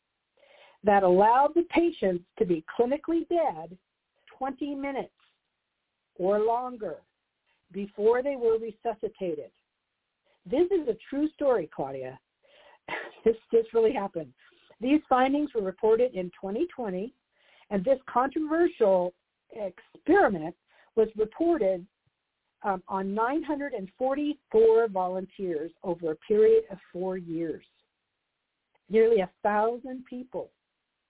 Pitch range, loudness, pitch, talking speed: 190-280 Hz, -27 LUFS, 225 Hz, 100 wpm